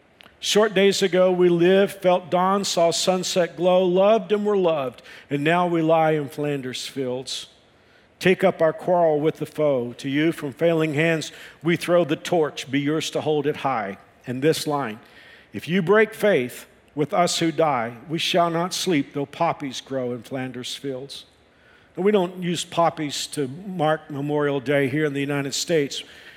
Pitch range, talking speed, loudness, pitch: 140-180 Hz, 175 wpm, -22 LUFS, 160 Hz